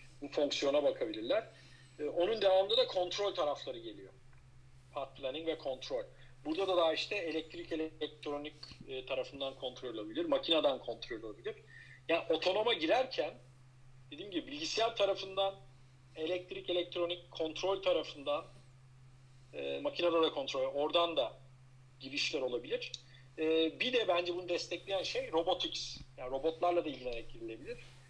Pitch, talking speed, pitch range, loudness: 155 Hz, 115 wpm, 130-180 Hz, -36 LUFS